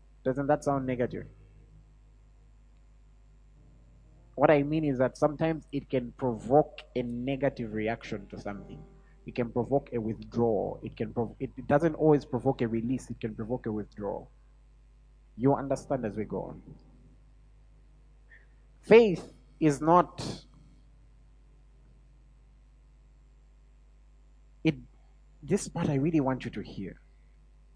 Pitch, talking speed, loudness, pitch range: 130 Hz, 120 wpm, -29 LUFS, 115-140 Hz